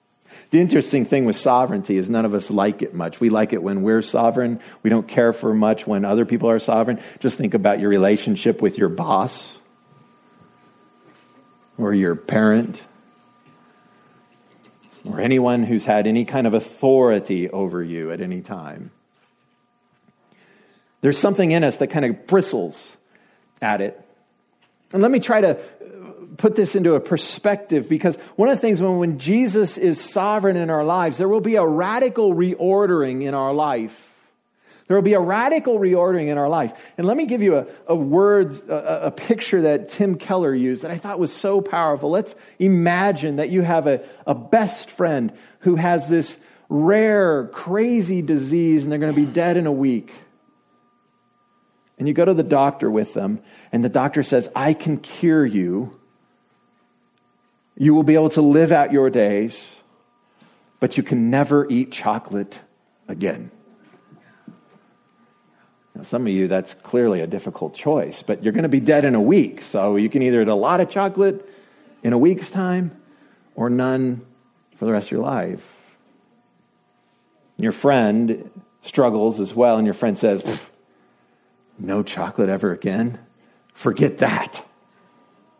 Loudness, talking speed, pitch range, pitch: -19 LUFS, 165 wpm, 115-190 Hz, 150 Hz